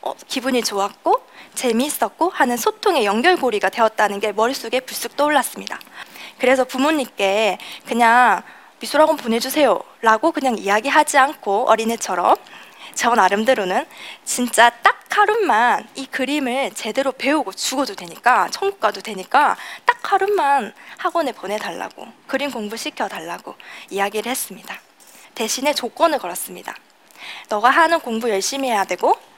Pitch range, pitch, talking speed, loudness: 220-295 Hz, 250 Hz, 330 characters per minute, -18 LUFS